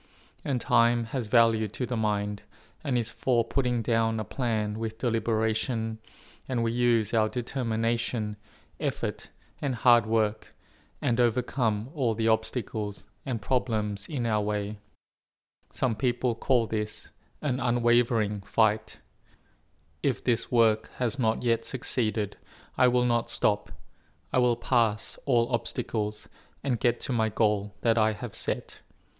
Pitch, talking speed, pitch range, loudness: 115 Hz, 140 wpm, 105-120 Hz, -28 LUFS